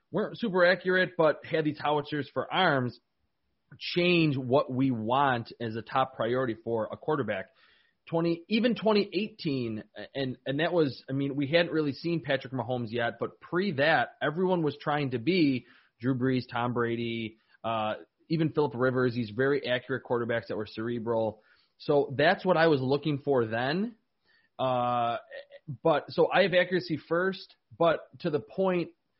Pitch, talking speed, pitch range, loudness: 145 Hz, 160 wpm, 120-170 Hz, -29 LUFS